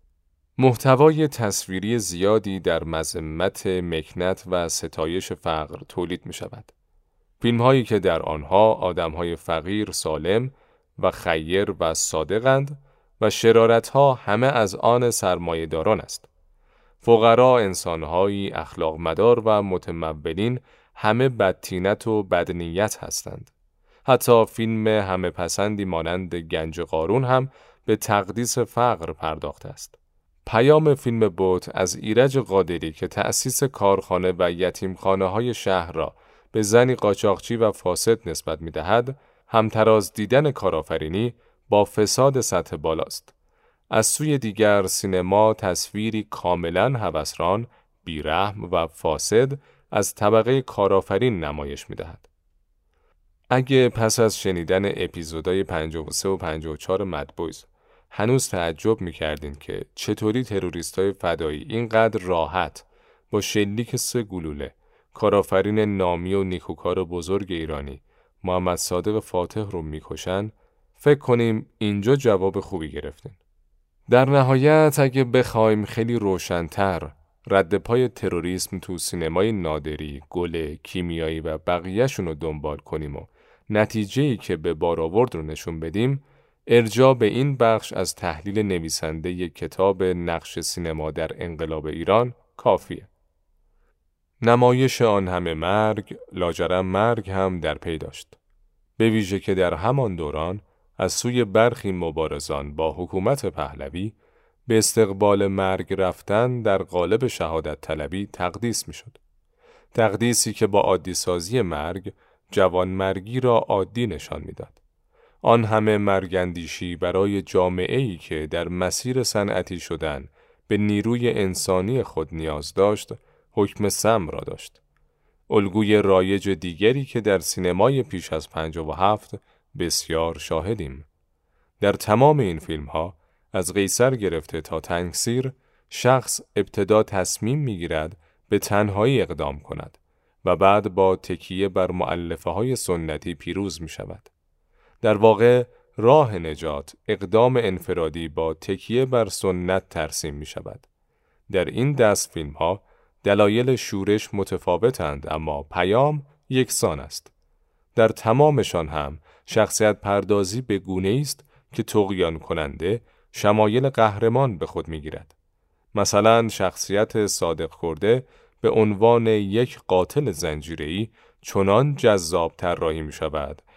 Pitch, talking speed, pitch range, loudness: 95 Hz, 120 wpm, 85-115 Hz, -22 LUFS